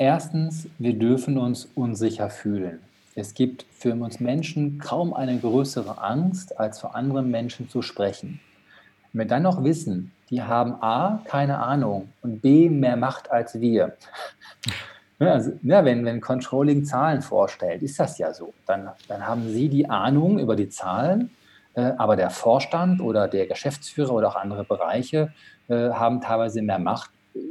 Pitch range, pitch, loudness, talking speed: 115-145 Hz, 125 Hz, -24 LUFS, 160 wpm